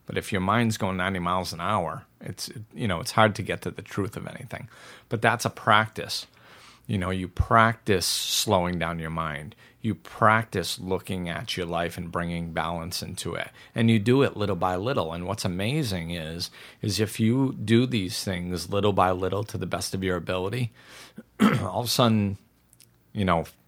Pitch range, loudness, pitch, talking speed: 90-110 Hz, -26 LUFS, 95 Hz, 195 wpm